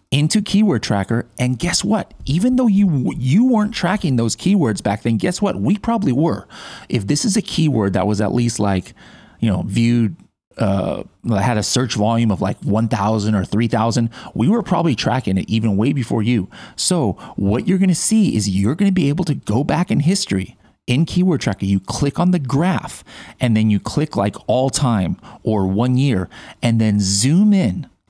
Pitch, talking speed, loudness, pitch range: 125 Hz, 195 wpm, -18 LUFS, 110-180 Hz